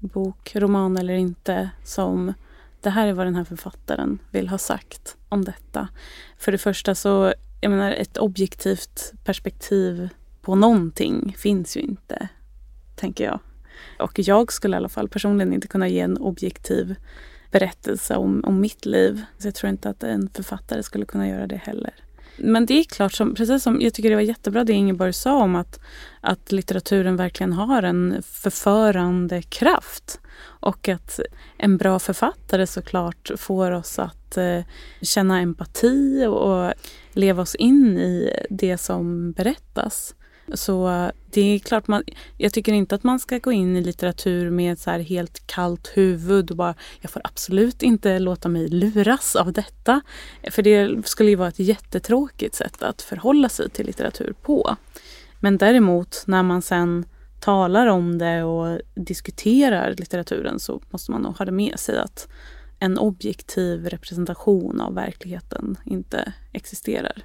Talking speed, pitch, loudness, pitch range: 160 wpm, 195 Hz, -21 LUFS, 175-215 Hz